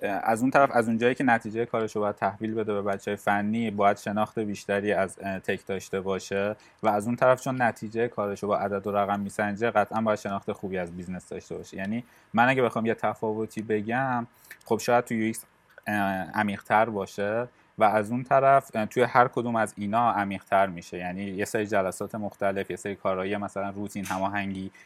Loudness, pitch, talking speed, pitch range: -27 LUFS, 105 Hz, 190 wpm, 100-115 Hz